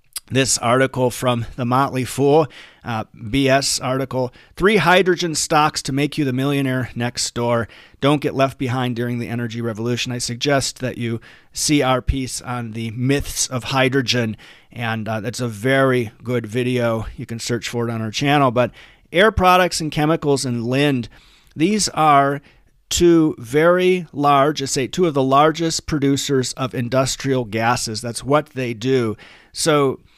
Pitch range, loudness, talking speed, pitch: 120-145 Hz, -19 LUFS, 160 wpm, 130 Hz